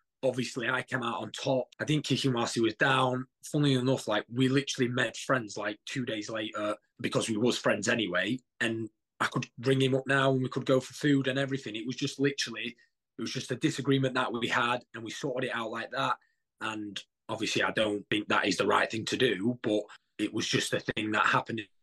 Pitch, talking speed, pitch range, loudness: 125 Hz, 230 wpm, 110-135 Hz, -30 LUFS